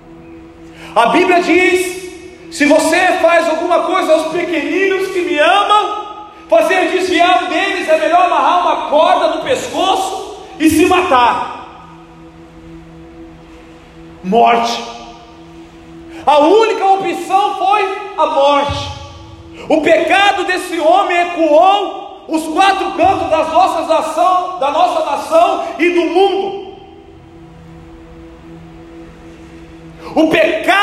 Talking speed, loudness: 100 wpm, -12 LUFS